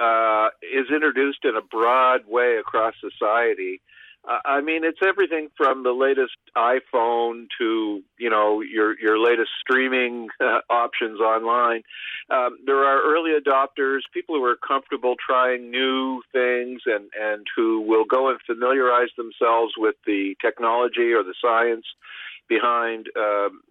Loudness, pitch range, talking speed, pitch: -21 LUFS, 115-135 Hz, 140 wpm, 125 Hz